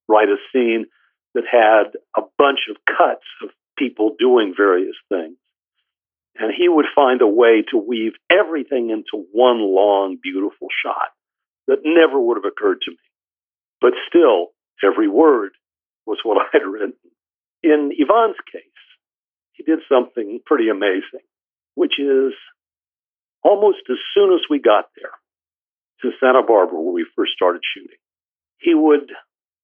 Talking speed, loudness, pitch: 145 wpm, -17 LUFS, 335 Hz